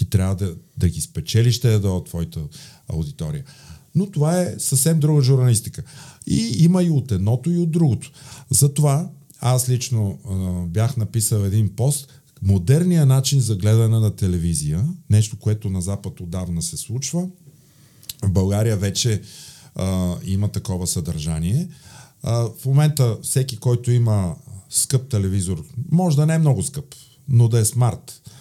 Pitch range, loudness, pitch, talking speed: 100-140 Hz, -20 LUFS, 120 Hz, 150 wpm